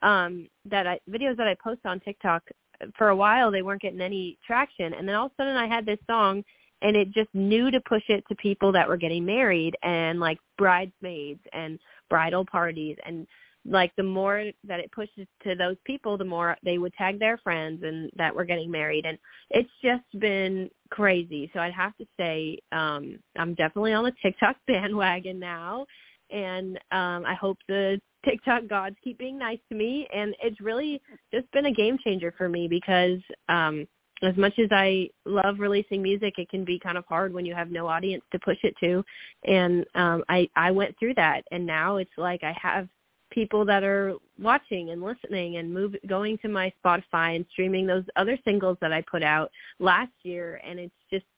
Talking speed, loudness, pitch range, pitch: 200 wpm, -26 LUFS, 175-210 Hz, 190 Hz